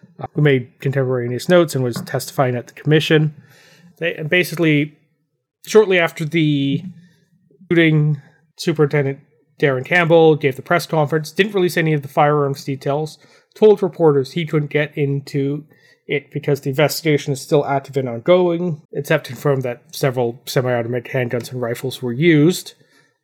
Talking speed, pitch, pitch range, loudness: 145 wpm, 150 Hz, 140-165 Hz, -18 LUFS